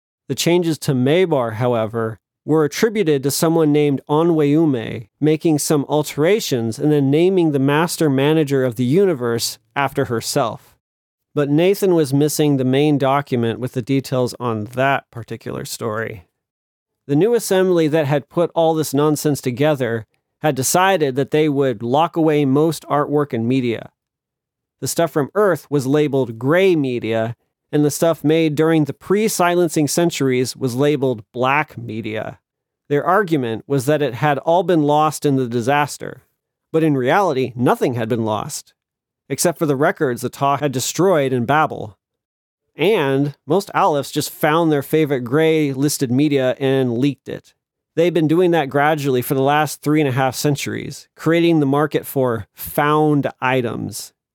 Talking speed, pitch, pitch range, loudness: 155 wpm, 145 Hz, 130-155 Hz, -18 LUFS